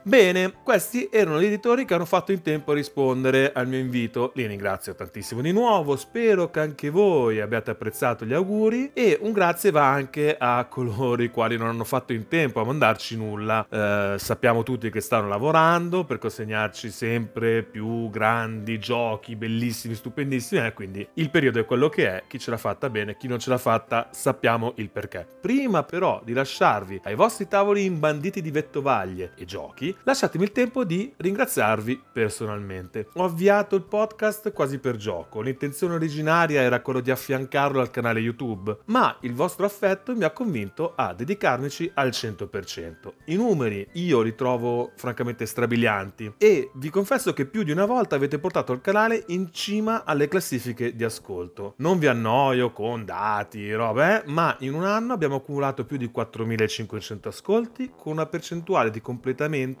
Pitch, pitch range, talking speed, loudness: 130 Hz, 115-185 Hz, 175 wpm, -24 LUFS